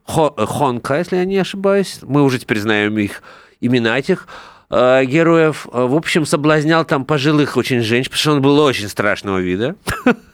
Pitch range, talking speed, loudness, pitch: 120-165 Hz, 155 wpm, -16 LUFS, 140 Hz